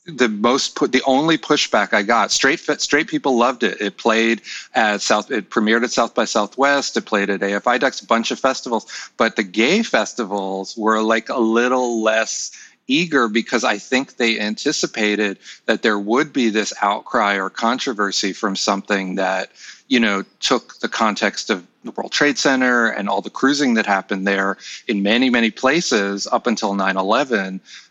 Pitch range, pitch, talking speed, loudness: 100-125 Hz, 110 Hz, 175 wpm, -18 LUFS